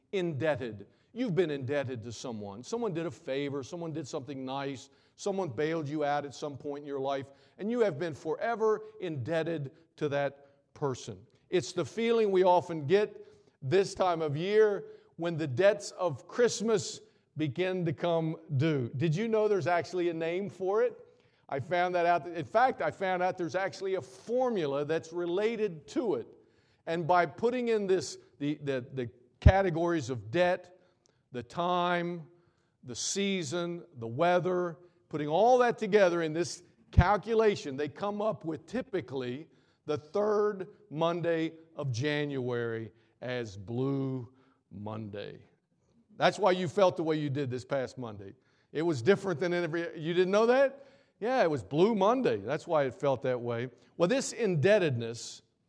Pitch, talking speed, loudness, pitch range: 165 Hz, 160 wpm, -31 LUFS, 140-190 Hz